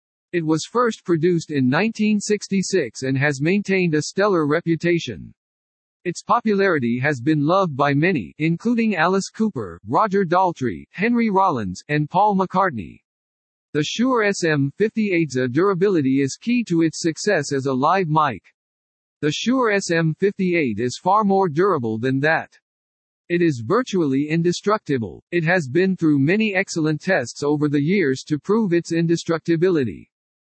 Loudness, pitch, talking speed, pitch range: -20 LUFS, 165 Hz, 135 wpm, 140-195 Hz